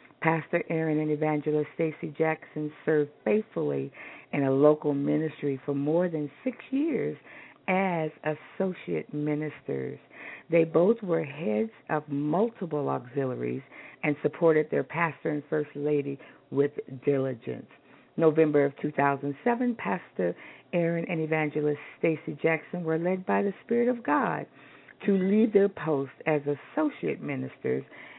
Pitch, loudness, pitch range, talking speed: 155 Hz, -28 LUFS, 145-165 Hz, 125 wpm